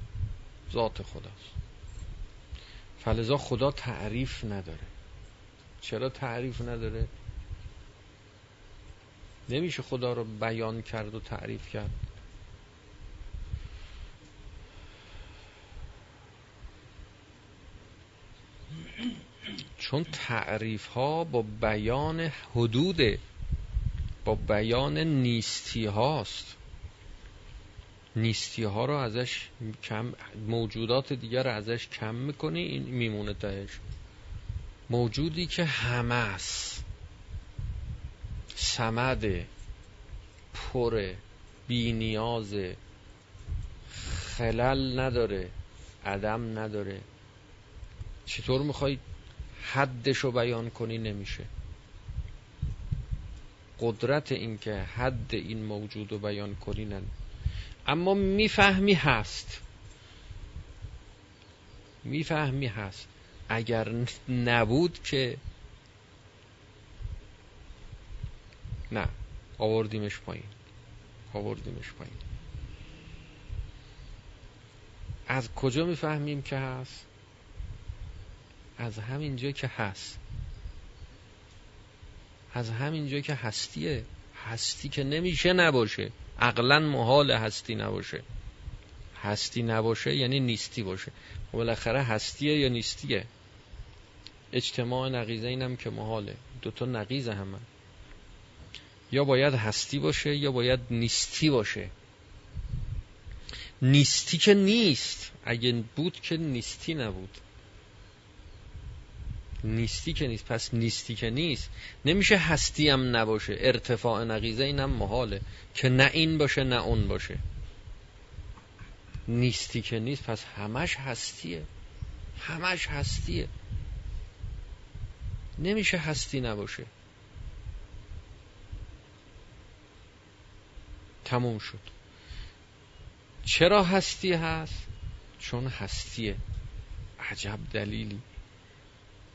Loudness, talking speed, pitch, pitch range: -30 LUFS, 80 wpm, 110 Hz, 100-125 Hz